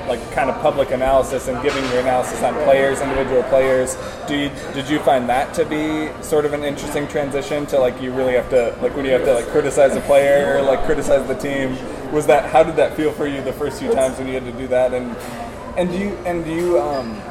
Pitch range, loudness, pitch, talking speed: 130-150 Hz, -18 LUFS, 140 Hz, 240 wpm